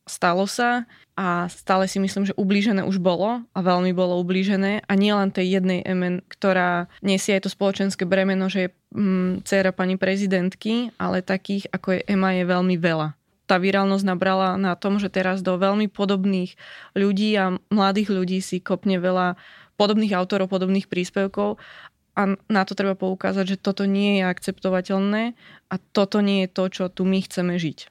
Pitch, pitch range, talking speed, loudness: 190 Hz, 185-200 Hz, 170 wpm, -22 LUFS